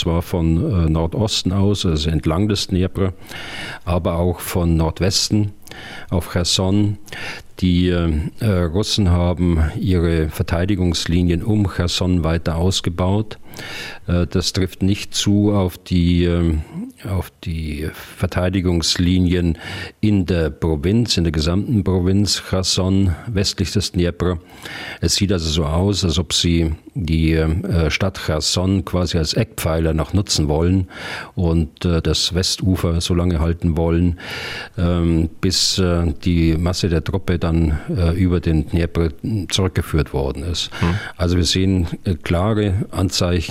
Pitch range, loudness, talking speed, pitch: 85-95 Hz, -19 LUFS, 115 wpm, 90 Hz